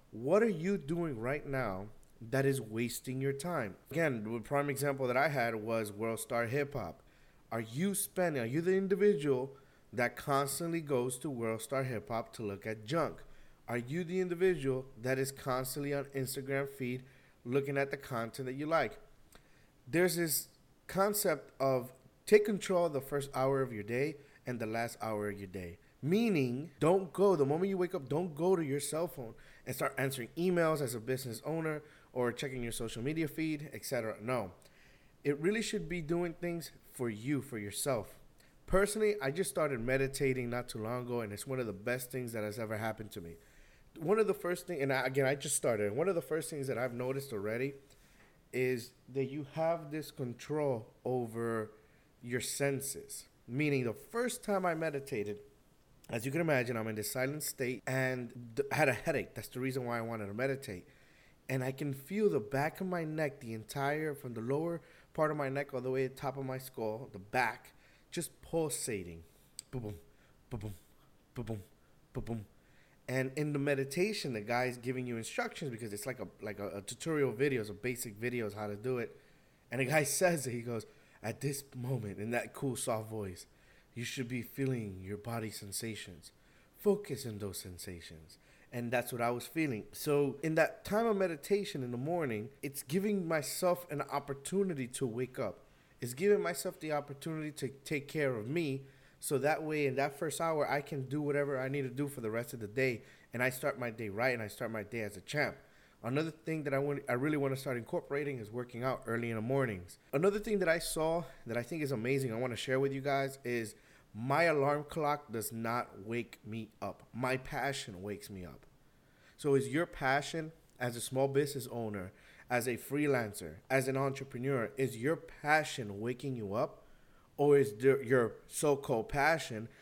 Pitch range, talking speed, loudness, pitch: 120-150 Hz, 200 wpm, -36 LUFS, 135 Hz